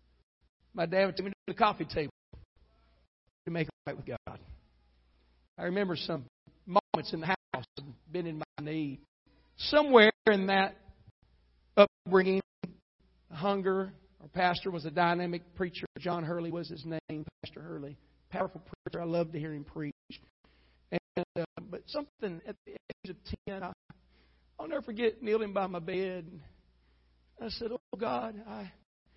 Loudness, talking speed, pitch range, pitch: -32 LUFS, 155 wpm, 135-195 Hz, 170 Hz